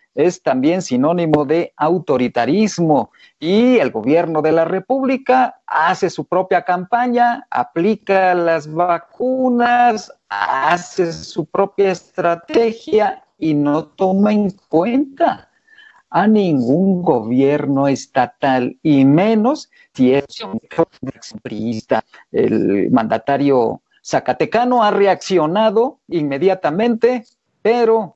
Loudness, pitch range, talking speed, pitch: -16 LUFS, 155-235 Hz, 90 wpm, 185 Hz